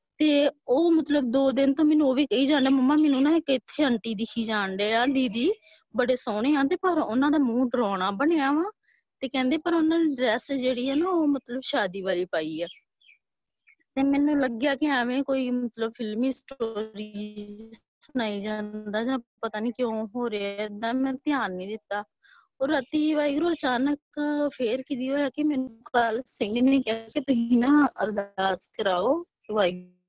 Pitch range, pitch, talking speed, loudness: 220-290 Hz, 260 Hz, 180 wpm, -26 LUFS